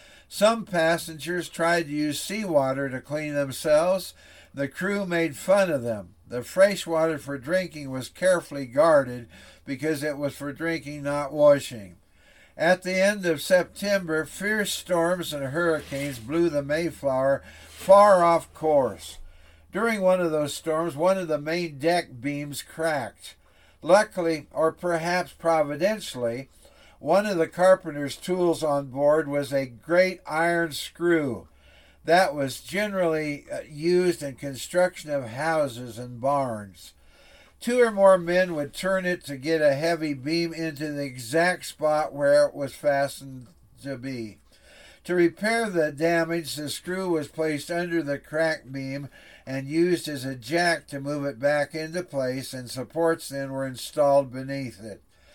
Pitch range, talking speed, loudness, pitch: 135-170 Hz, 145 wpm, -25 LUFS, 150 Hz